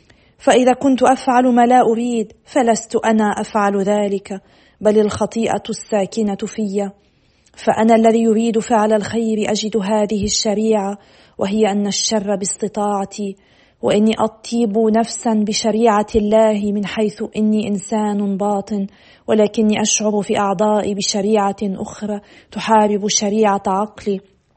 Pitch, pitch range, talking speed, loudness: 215 Hz, 205-220 Hz, 110 wpm, -17 LUFS